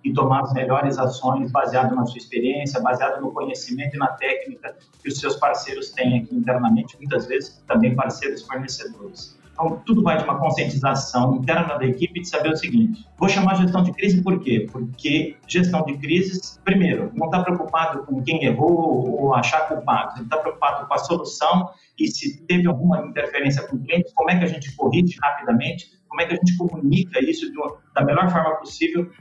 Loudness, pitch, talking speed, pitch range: -21 LUFS, 160 Hz, 195 wpm, 135-180 Hz